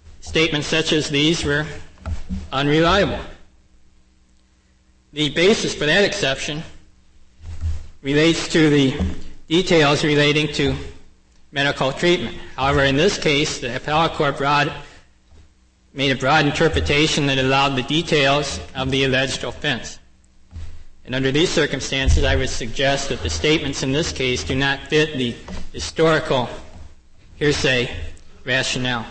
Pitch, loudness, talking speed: 135 Hz, -19 LUFS, 120 wpm